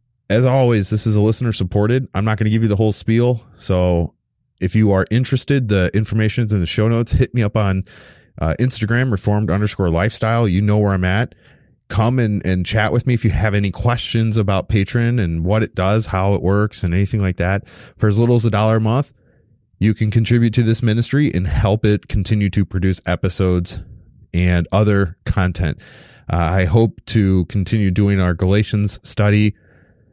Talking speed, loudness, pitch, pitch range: 195 wpm, -17 LUFS, 105 Hz, 95-115 Hz